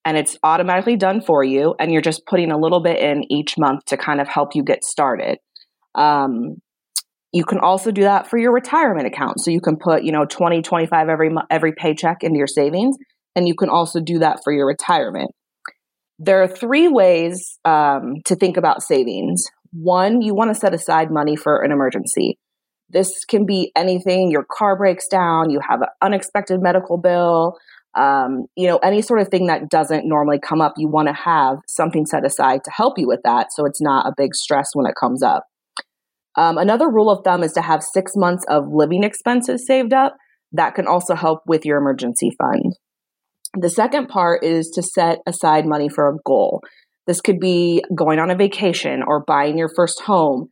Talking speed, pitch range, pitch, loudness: 200 wpm, 150-190 Hz, 170 Hz, -17 LUFS